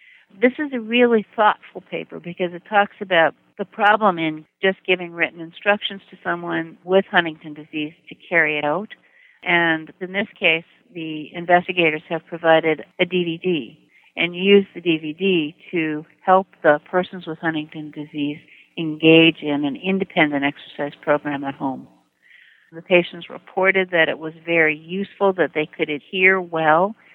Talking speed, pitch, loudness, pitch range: 150 wpm, 170 Hz, -20 LUFS, 155-190 Hz